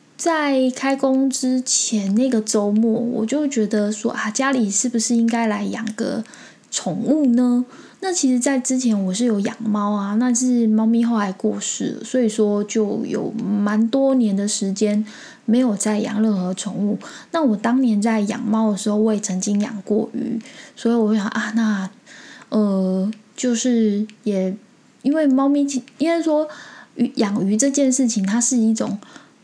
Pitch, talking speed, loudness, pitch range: 230 Hz, 230 characters per minute, -20 LUFS, 210-255 Hz